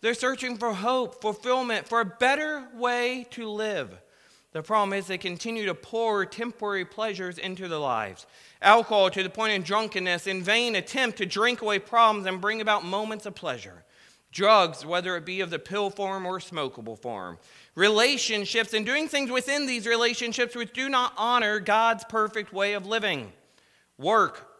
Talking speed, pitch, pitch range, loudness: 170 wpm, 215 Hz, 190-235 Hz, -26 LUFS